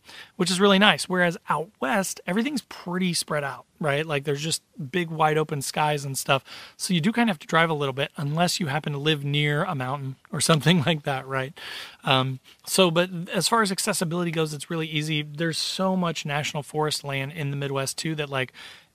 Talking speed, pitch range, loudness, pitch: 215 wpm, 145-180 Hz, -25 LUFS, 155 Hz